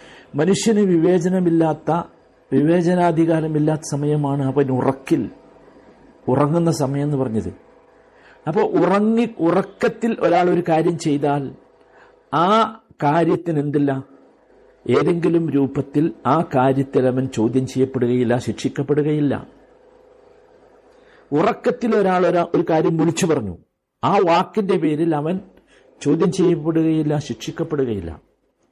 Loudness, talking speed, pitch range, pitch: -19 LUFS, 90 wpm, 140-180 Hz, 160 Hz